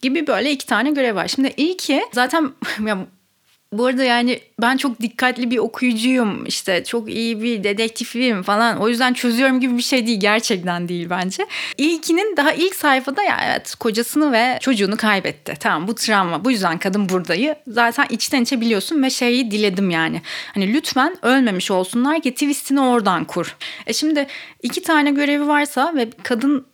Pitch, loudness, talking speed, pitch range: 245 Hz, -18 LUFS, 170 wpm, 220-275 Hz